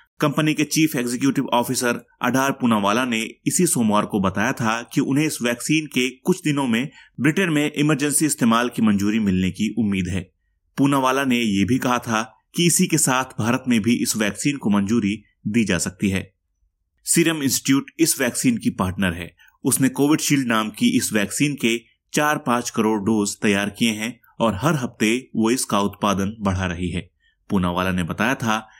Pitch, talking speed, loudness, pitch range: 120 Hz, 180 wpm, -21 LUFS, 105-140 Hz